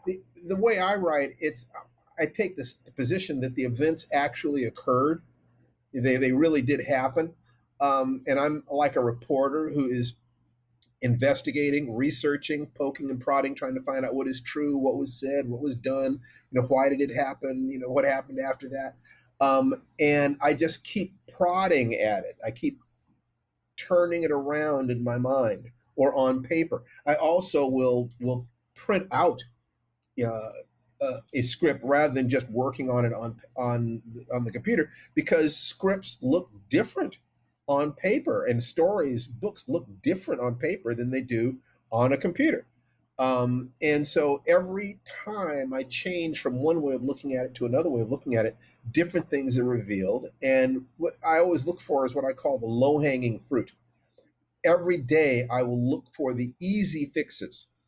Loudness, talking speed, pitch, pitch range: -27 LUFS, 170 wpm, 135 Hz, 125-150 Hz